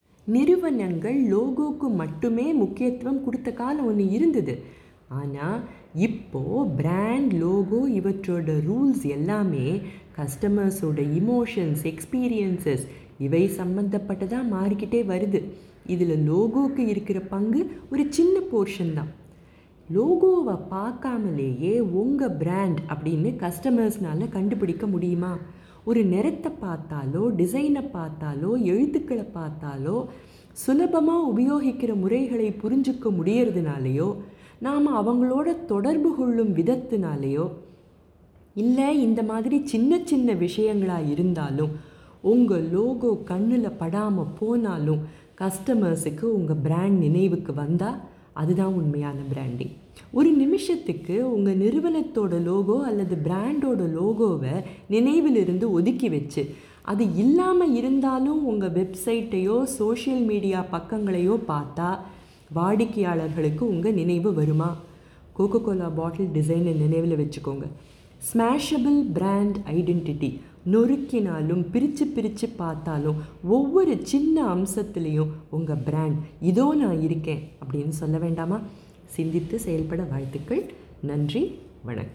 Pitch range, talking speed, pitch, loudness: 165-240 Hz, 95 wpm, 195 Hz, -24 LUFS